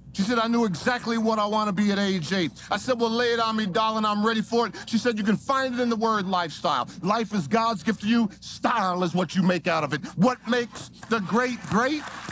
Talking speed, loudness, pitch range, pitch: 265 wpm, -25 LUFS, 190-235 Hz, 220 Hz